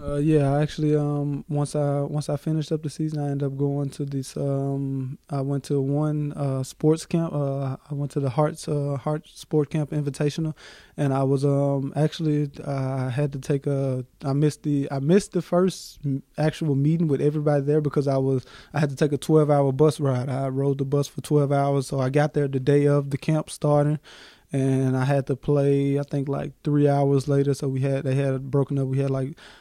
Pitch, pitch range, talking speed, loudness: 145 Hz, 140-150 Hz, 220 wpm, -24 LUFS